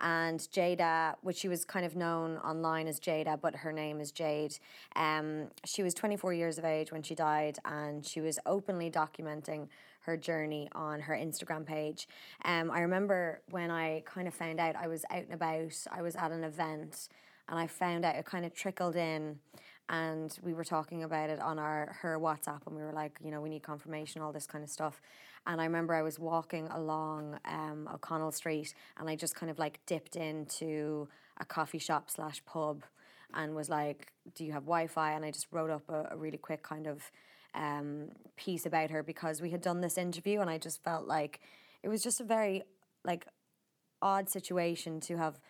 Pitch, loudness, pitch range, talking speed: 160 Hz, -37 LUFS, 155-170 Hz, 205 wpm